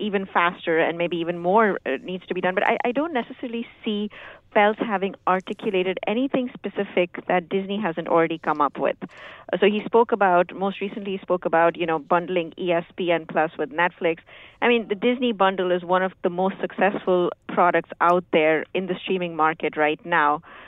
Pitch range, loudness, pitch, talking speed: 170-205 Hz, -23 LUFS, 185 Hz, 185 wpm